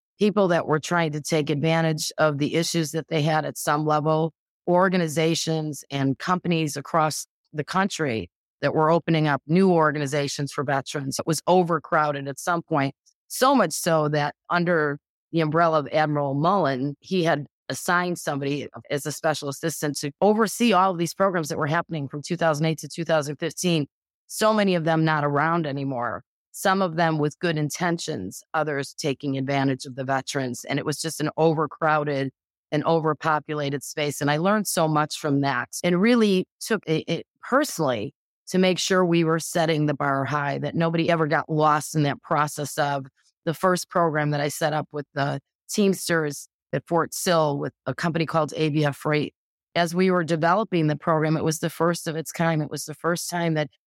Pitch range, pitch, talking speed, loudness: 145-170 Hz, 155 Hz, 180 wpm, -24 LUFS